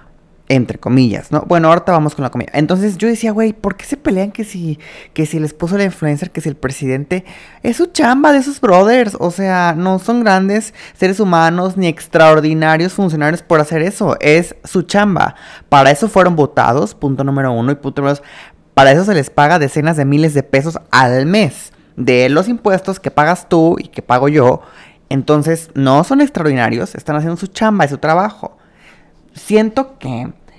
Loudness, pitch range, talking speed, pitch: -13 LUFS, 145-195 Hz, 190 wpm, 165 Hz